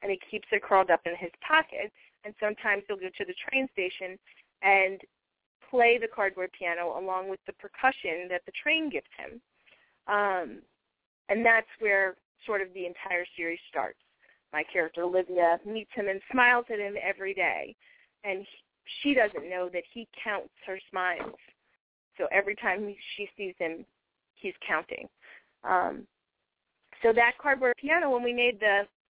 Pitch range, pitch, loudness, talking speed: 185-235 Hz, 200 Hz, -28 LUFS, 165 wpm